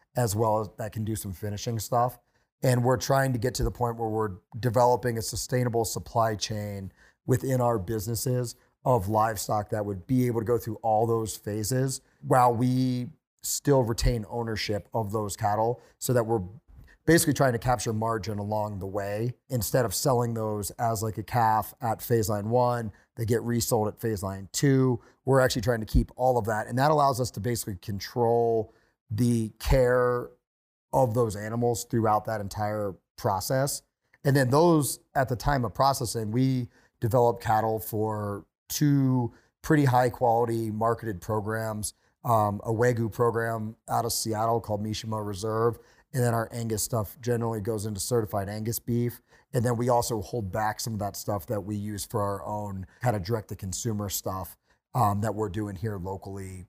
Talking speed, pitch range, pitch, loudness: 175 wpm, 105-125 Hz, 115 Hz, -27 LUFS